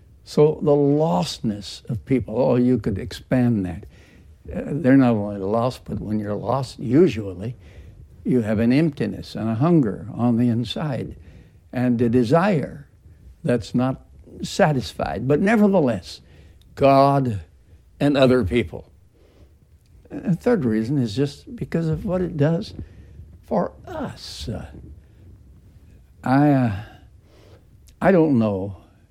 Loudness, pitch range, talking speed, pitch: -21 LUFS, 95-140 Hz, 125 wpm, 115 Hz